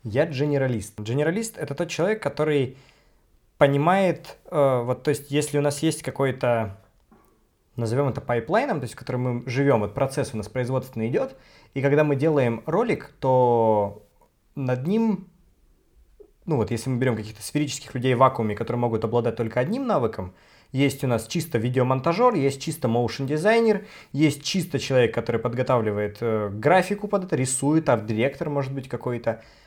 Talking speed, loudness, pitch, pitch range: 155 wpm, -24 LUFS, 130 Hz, 115-150 Hz